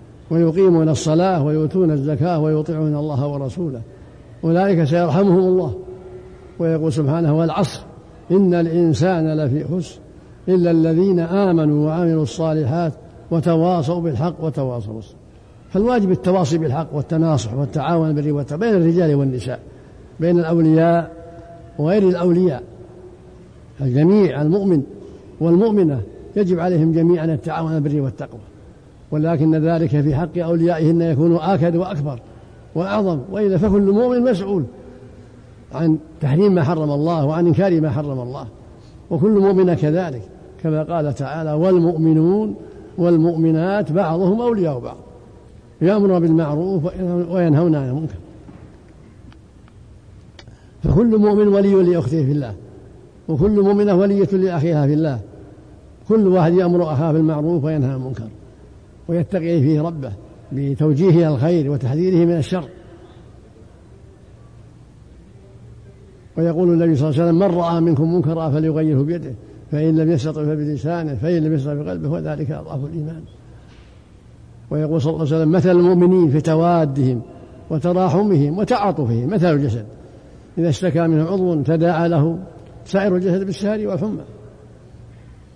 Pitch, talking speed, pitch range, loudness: 160 Hz, 110 wpm, 140-175 Hz, -18 LUFS